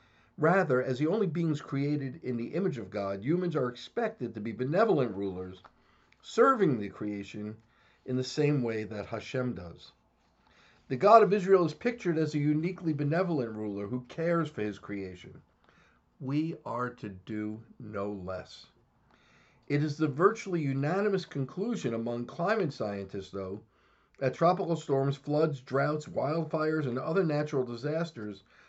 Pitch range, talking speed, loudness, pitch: 110-165 Hz, 145 wpm, -30 LUFS, 135 Hz